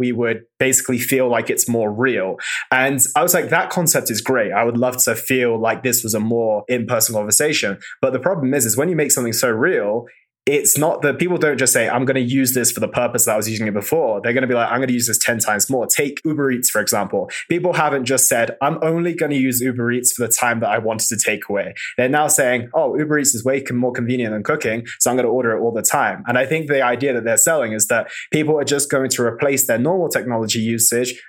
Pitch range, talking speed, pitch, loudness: 115-140 Hz, 260 wpm, 125 Hz, -17 LUFS